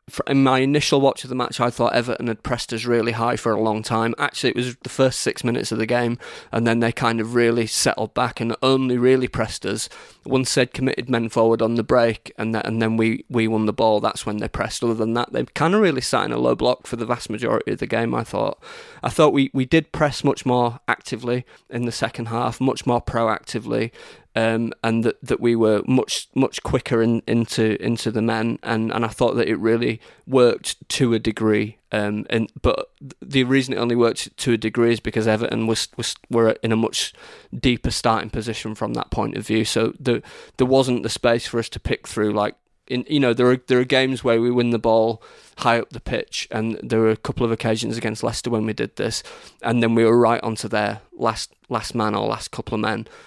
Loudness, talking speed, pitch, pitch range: -21 LUFS, 235 wpm, 115 Hz, 110-125 Hz